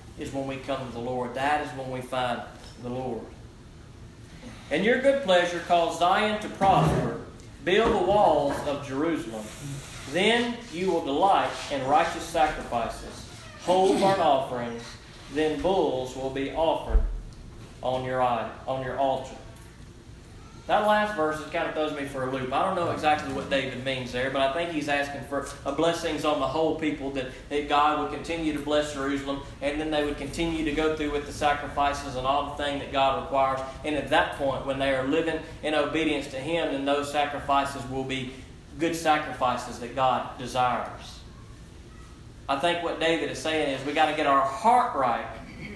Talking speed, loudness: 180 wpm, -26 LUFS